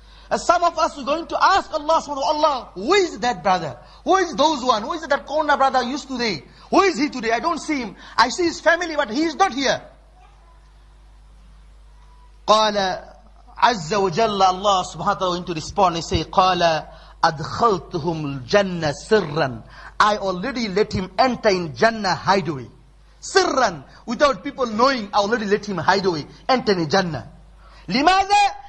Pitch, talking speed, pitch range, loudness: 225 Hz, 160 wpm, 185-295 Hz, -20 LUFS